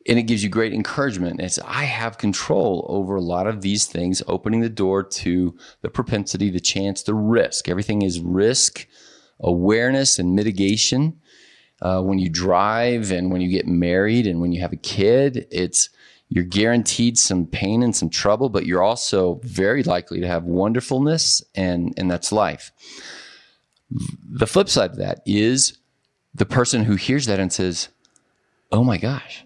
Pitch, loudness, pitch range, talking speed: 100 Hz, -20 LUFS, 90-120 Hz, 170 wpm